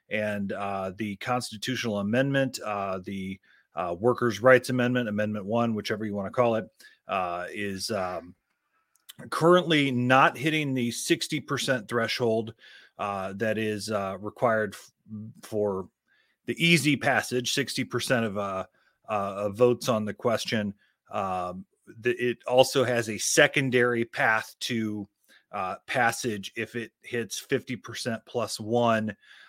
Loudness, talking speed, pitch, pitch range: -27 LUFS, 130 wpm, 115 Hz, 105-125 Hz